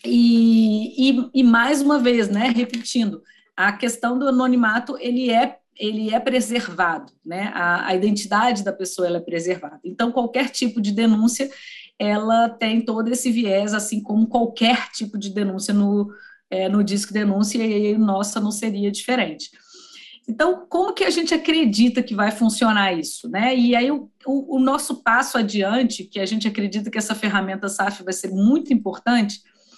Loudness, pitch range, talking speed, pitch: -20 LUFS, 205-250 Hz, 170 wpm, 230 Hz